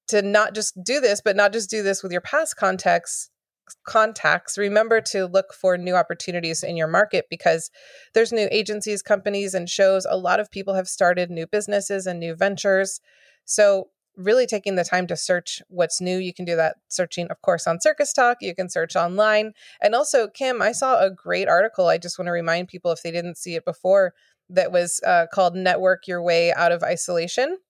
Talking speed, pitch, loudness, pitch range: 205 wpm, 190 Hz, -21 LUFS, 175-210 Hz